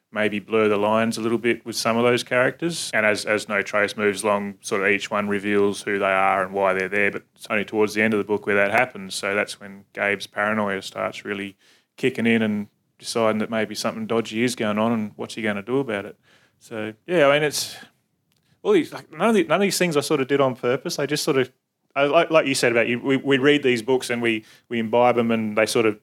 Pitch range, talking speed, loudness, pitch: 105-125 Hz, 265 wpm, -22 LUFS, 110 Hz